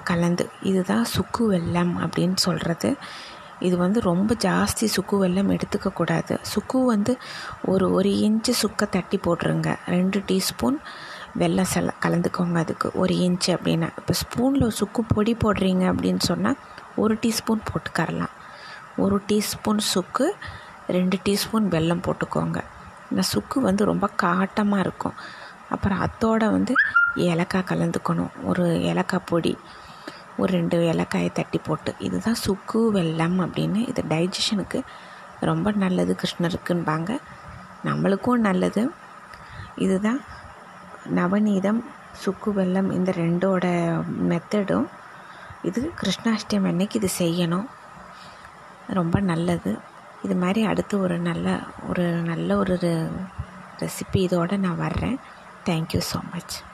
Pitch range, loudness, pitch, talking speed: 175-210 Hz, -24 LUFS, 190 Hz, 110 wpm